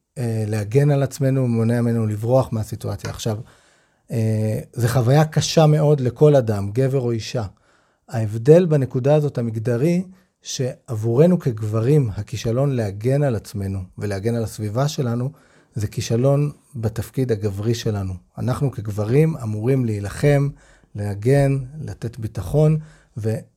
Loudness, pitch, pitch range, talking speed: -20 LUFS, 120 Hz, 110-140 Hz, 110 wpm